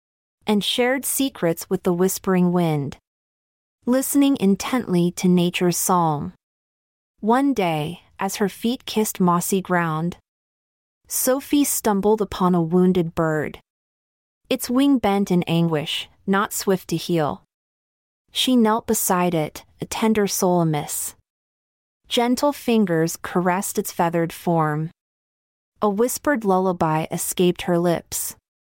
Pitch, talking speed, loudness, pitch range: 185 Hz, 115 wpm, -21 LUFS, 170-225 Hz